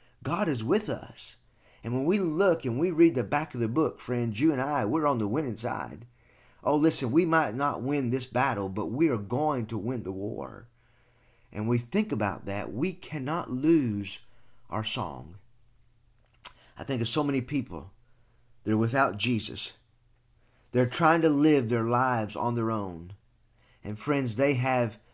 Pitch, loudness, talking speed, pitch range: 120 Hz, -28 LUFS, 175 wpm, 115-140 Hz